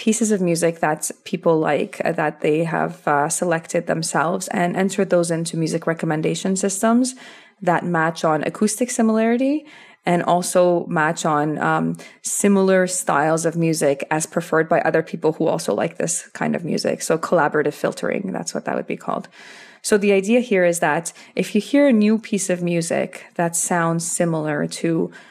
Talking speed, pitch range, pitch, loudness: 170 wpm, 160-200 Hz, 175 Hz, -20 LUFS